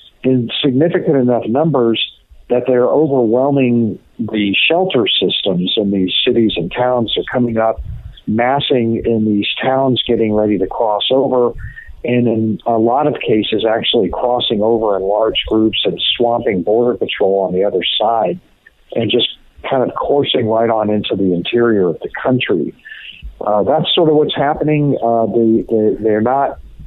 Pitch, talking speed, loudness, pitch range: 115 Hz, 160 wpm, -14 LUFS, 105-125 Hz